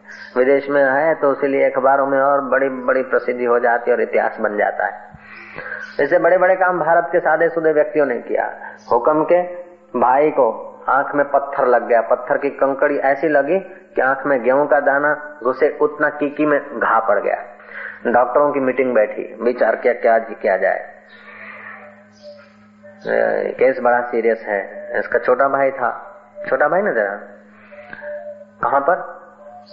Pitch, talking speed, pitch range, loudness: 145 Hz, 155 wpm, 135-180 Hz, -17 LUFS